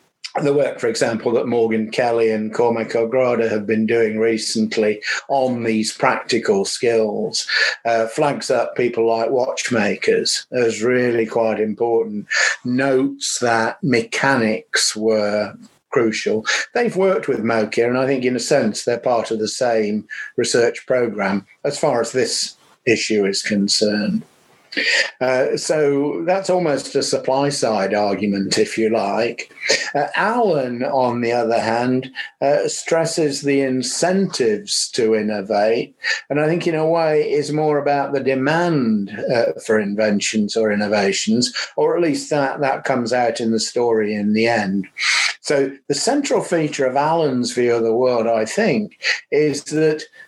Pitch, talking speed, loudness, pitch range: 120 Hz, 145 wpm, -18 LUFS, 110-145 Hz